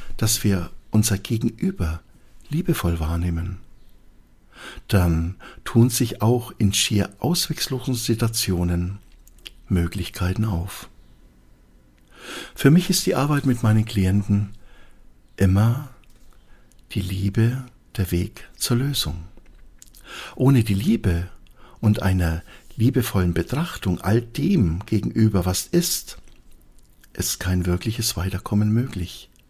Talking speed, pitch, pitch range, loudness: 100 wpm, 95 Hz, 85-115 Hz, -22 LUFS